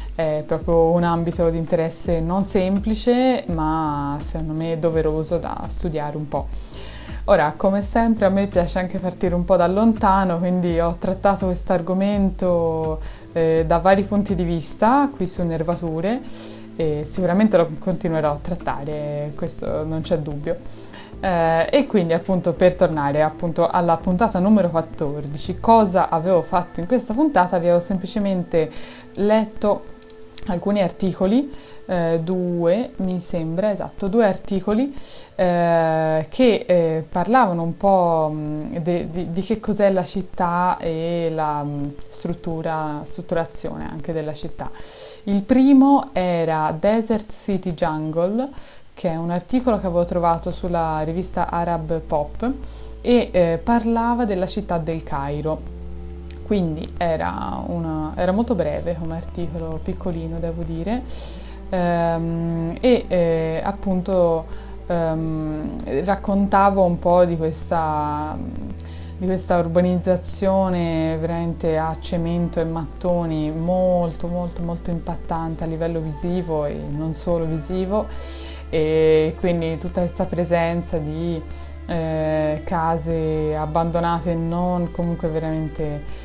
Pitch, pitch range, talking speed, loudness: 170 Hz, 160-190 Hz, 125 wpm, -21 LUFS